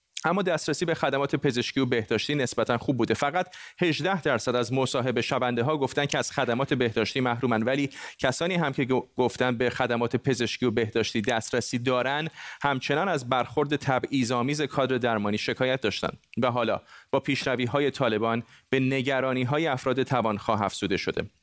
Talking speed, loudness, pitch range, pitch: 155 wpm, -27 LUFS, 120-140 Hz, 130 Hz